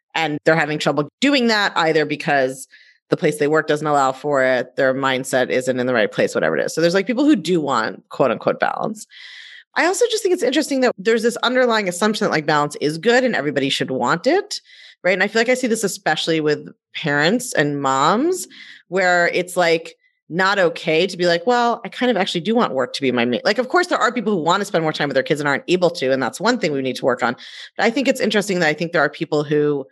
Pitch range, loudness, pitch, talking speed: 145-235 Hz, -18 LUFS, 170 Hz, 260 wpm